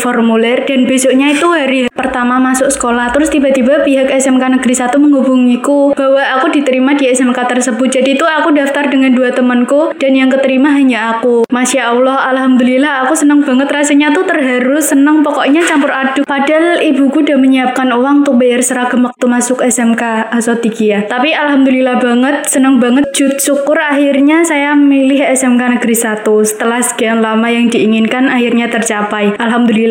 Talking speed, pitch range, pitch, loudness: 160 wpm, 245-280 Hz, 260 Hz, -10 LUFS